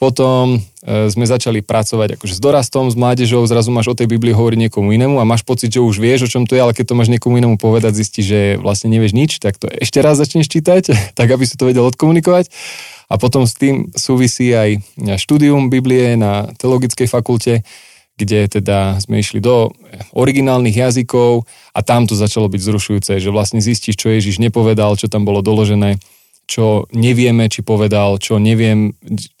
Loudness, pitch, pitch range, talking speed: -13 LUFS, 115 Hz, 105-125 Hz, 190 wpm